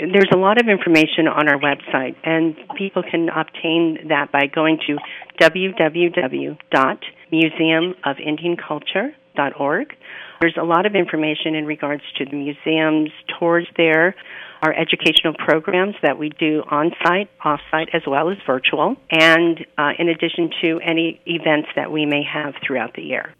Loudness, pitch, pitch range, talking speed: -18 LUFS, 160 Hz, 150-170 Hz, 140 wpm